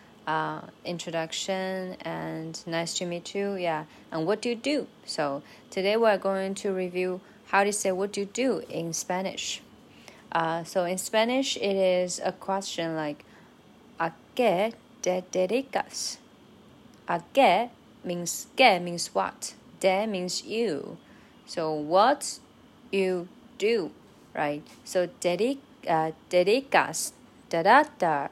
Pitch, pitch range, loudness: 185 Hz, 165-210 Hz, -28 LUFS